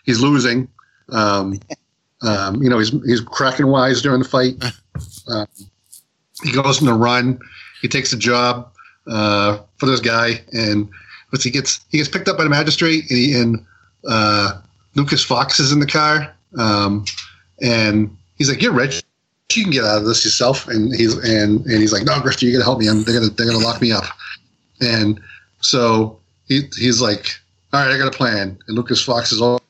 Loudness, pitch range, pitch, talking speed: -16 LUFS, 105-130 Hz, 120 Hz, 200 wpm